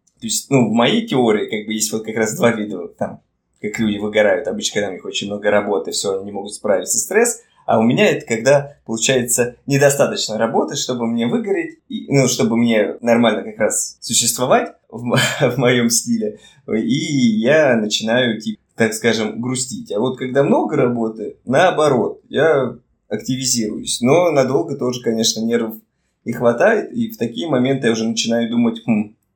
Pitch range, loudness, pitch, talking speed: 110-135 Hz, -17 LUFS, 120 Hz, 175 wpm